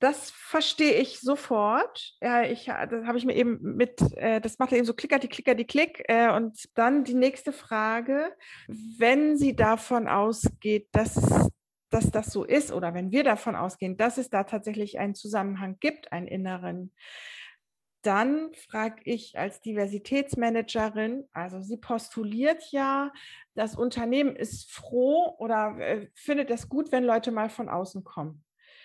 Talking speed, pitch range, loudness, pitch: 150 wpm, 215-270 Hz, -27 LUFS, 235 Hz